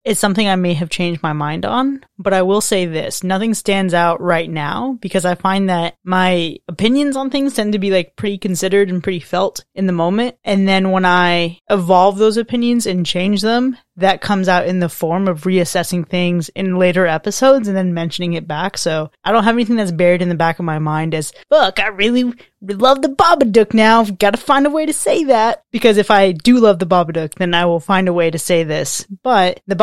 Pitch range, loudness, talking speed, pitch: 175-220 Hz, -15 LUFS, 230 wpm, 190 Hz